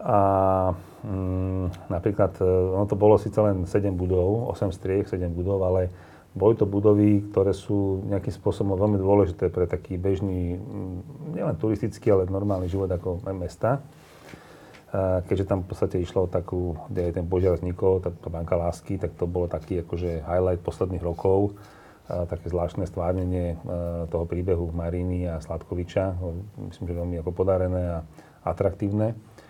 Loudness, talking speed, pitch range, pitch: -26 LUFS, 155 wpm, 90-100 Hz, 95 Hz